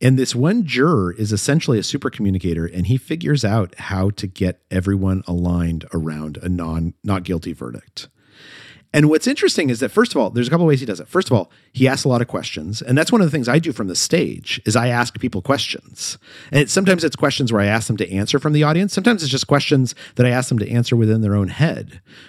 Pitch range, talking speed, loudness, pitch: 95-145 Hz, 250 wpm, -18 LUFS, 120 Hz